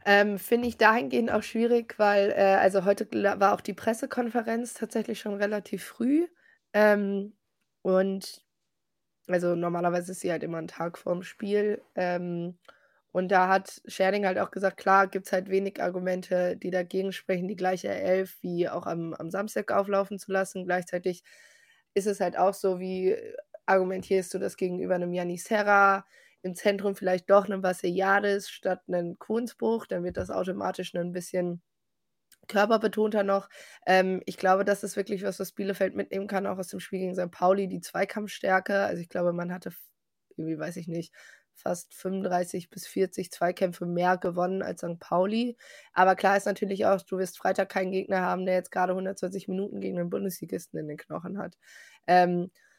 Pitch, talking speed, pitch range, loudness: 190 Hz, 175 wpm, 180-200 Hz, -28 LUFS